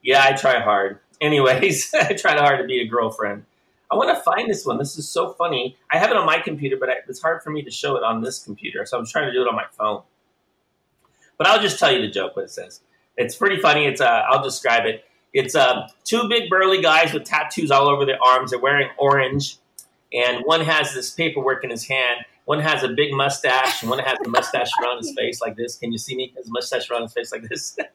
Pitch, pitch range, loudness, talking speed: 140 Hz, 130-165 Hz, -20 LUFS, 245 wpm